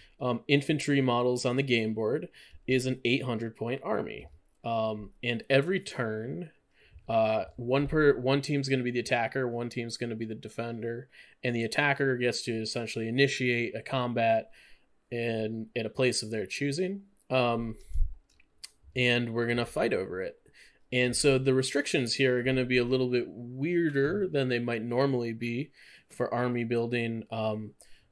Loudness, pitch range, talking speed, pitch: -29 LUFS, 115-135 Hz, 165 wpm, 120 Hz